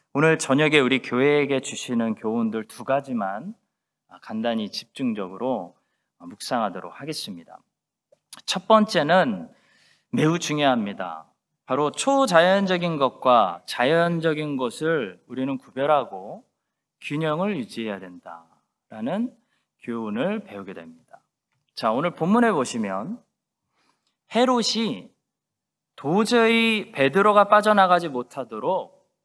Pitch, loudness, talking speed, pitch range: 160 Hz, -22 LUFS, 245 characters per minute, 125-215 Hz